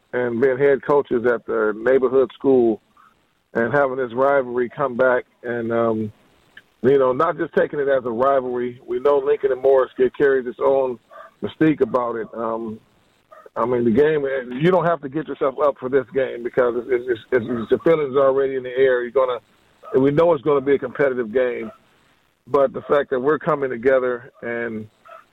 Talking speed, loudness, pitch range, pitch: 195 wpm, -20 LUFS, 125-150 Hz, 135 Hz